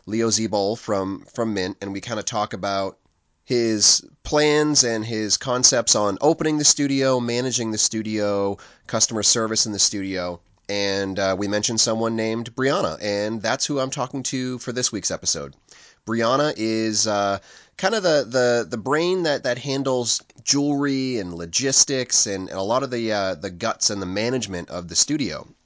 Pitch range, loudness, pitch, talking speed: 100-130 Hz, -21 LUFS, 115 Hz, 175 wpm